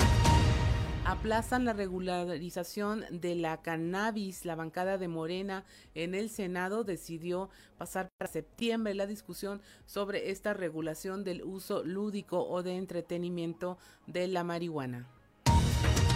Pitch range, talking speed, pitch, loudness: 165-195 Hz, 115 wpm, 180 Hz, -34 LUFS